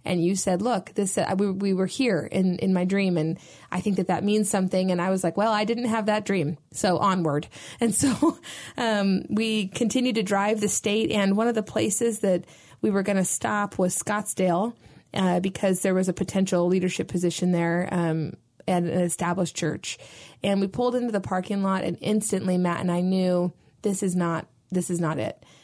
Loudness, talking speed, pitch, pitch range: -25 LUFS, 205 wpm, 190 Hz, 175-210 Hz